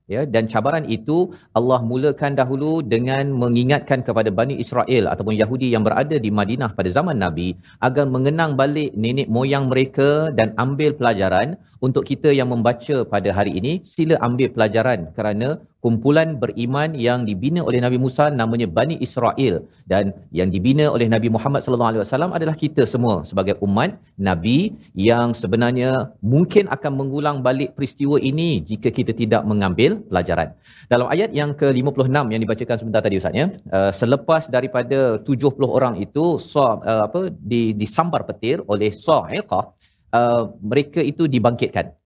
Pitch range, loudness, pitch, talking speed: 110-140 Hz, -19 LUFS, 125 Hz, 155 wpm